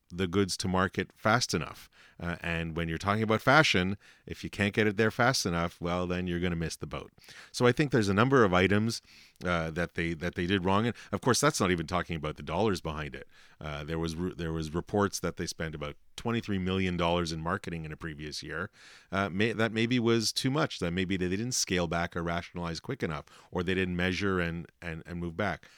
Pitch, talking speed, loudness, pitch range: 90 Hz, 235 wpm, -30 LUFS, 85-100 Hz